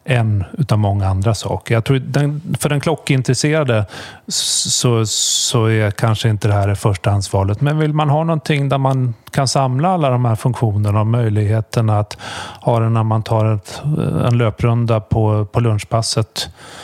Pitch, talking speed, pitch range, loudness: 115 Hz, 165 wpm, 110-140 Hz, -16 LUFS